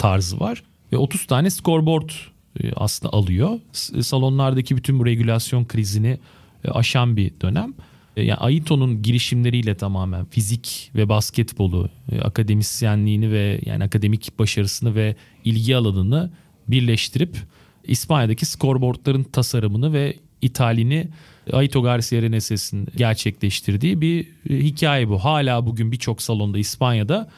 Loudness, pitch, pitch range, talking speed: -20 LUFS, 120 Hz, 110-135 Hz, 105 wpm